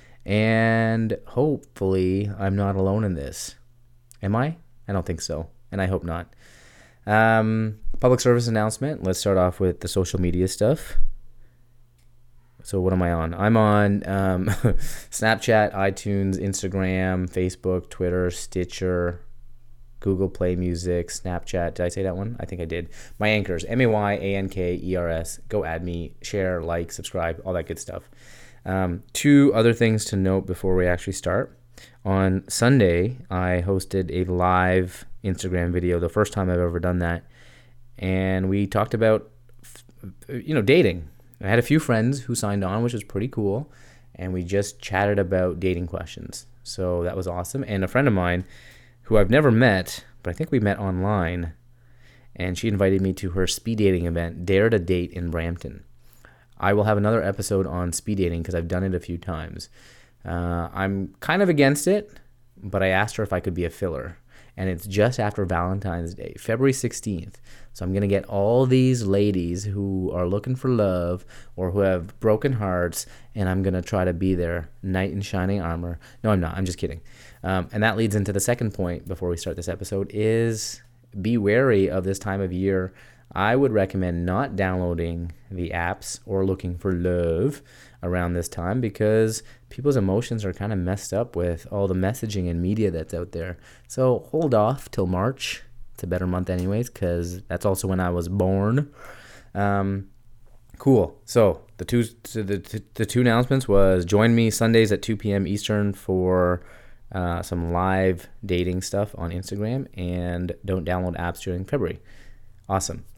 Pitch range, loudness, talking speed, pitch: 90-115 Hz, -24 LUFS, 180 wpm, 95 Hz